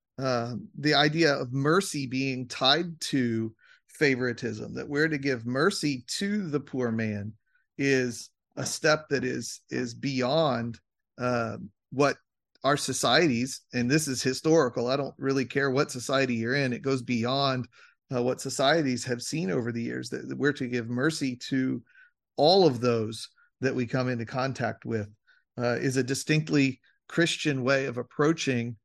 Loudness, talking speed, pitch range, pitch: -27 LUFS, 155 wpm, 120-145 Hz, 130 Hz